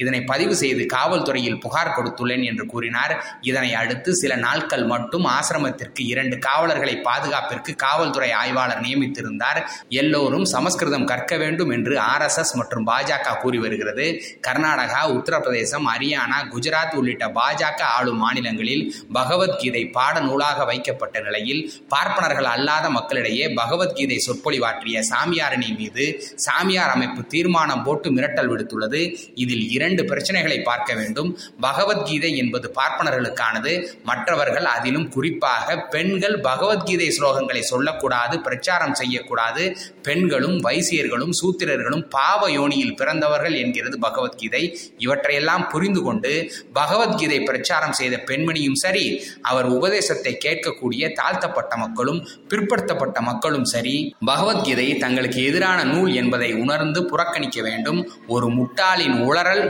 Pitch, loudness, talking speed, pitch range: 135 Hz, -21 LUFS, 100 wpm, 125-175 Hz